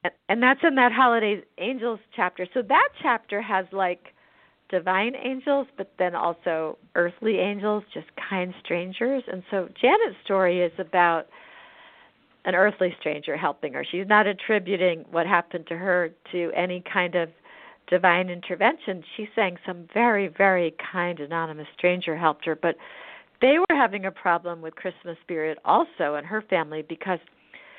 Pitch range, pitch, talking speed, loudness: 175-215 Hz, 185 Hz, 150 wpm, -24 LUFS